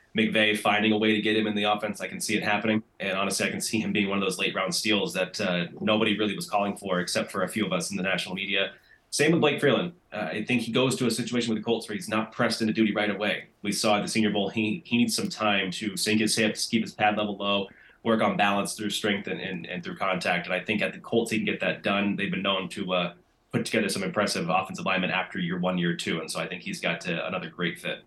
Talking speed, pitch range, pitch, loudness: 290 wpm, 100-110 Hz, 105 Hz, -26 LUFS